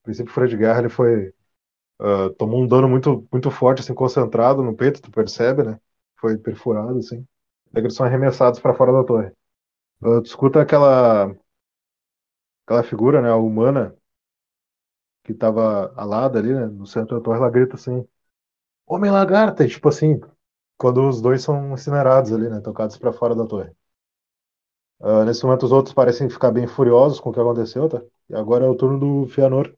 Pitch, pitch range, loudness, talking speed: 120 Hz, 110-130 Hz, -18 LUFS, 175 wpm